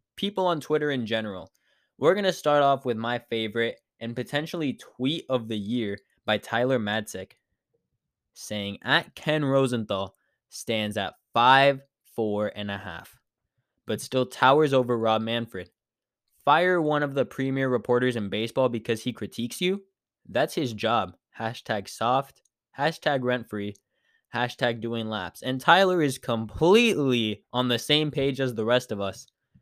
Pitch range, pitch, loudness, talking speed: 110-140 Hz, 120 Hz, -26 LUFS, 150 wpm